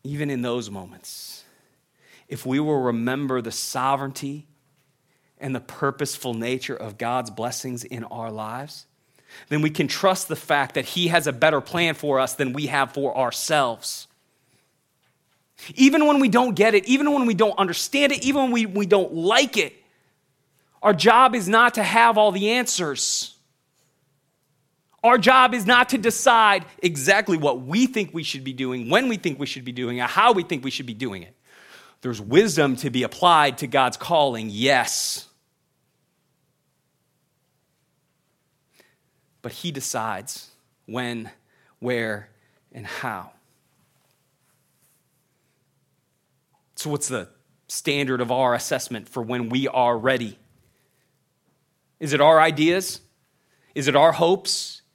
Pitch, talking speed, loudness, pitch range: 140 Hz, 145 wpm, -21 LUFS, 125-175 Hz